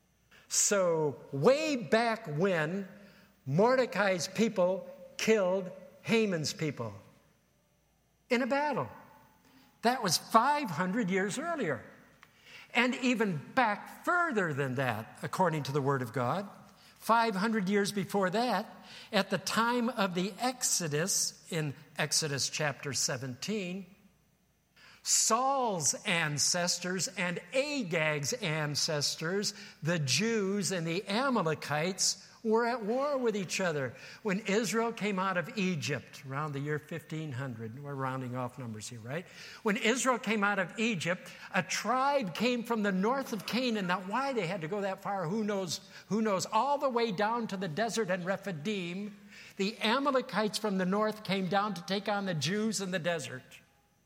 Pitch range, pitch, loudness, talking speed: 165-225 Hz, 195 Hz, -31 LUFS, 140 wpm